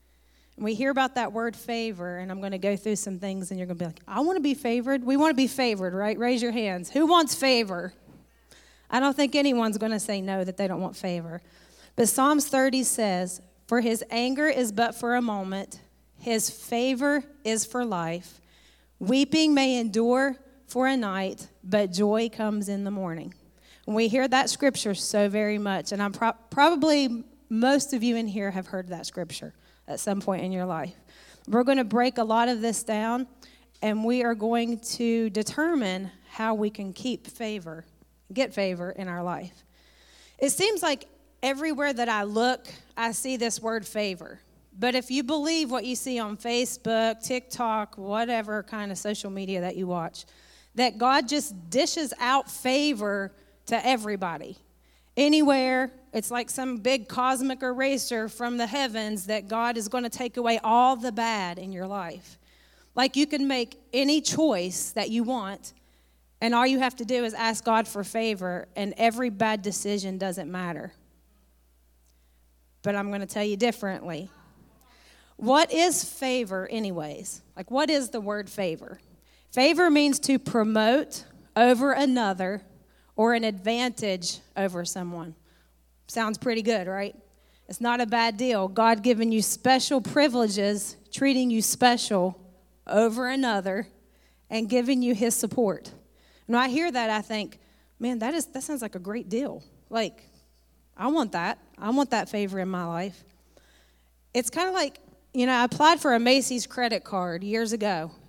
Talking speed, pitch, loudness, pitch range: 175 wpm, 225 Hz, -26 LUFS, 195-255 Hz